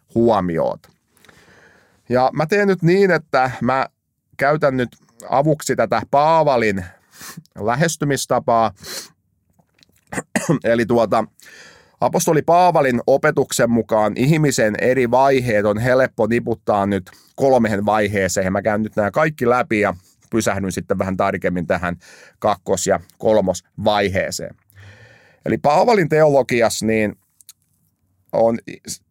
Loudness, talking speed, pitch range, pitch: -18 LUFS, 100 wpm, 105-135 Hz, 115 Hz